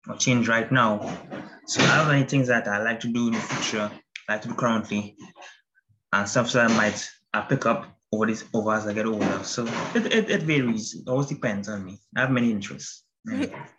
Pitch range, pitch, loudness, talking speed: 105-130 Hz, 115 Hz, -24 LUFS, 225 wpm